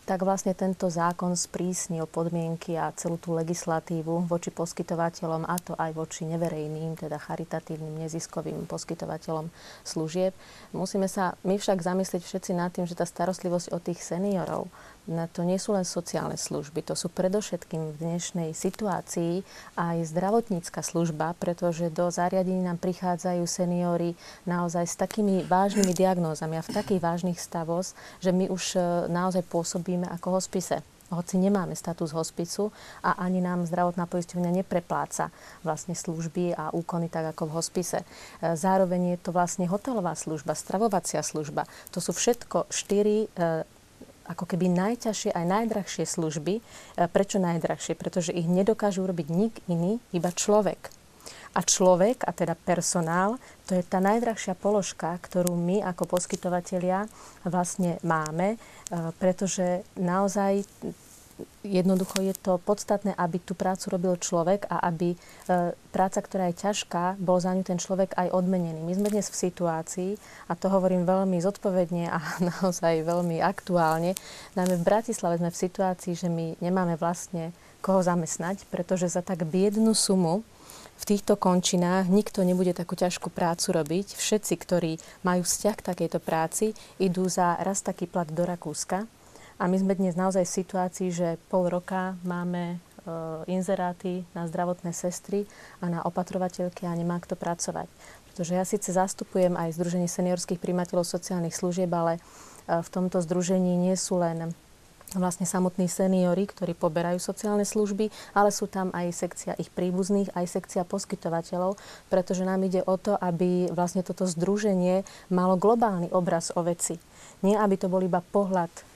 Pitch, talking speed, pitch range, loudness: 180 Hz, 145 wpm, 170-190 Hz, -28 LUFS